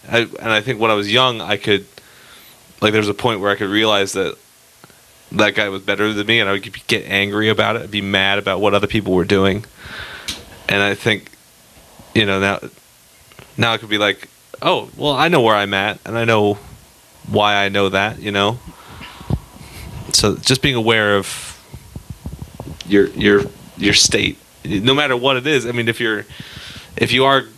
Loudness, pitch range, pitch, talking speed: -16 LUFS, 100-115 Hz, 105 Hz, 195 wpm